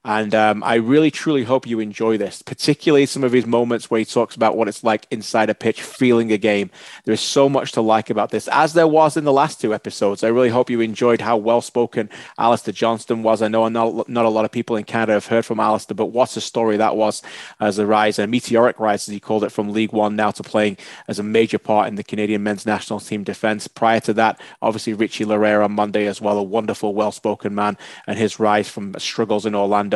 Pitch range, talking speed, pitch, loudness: 105-115 Hz, 245 wpm, 110 Hz, -19 LUFS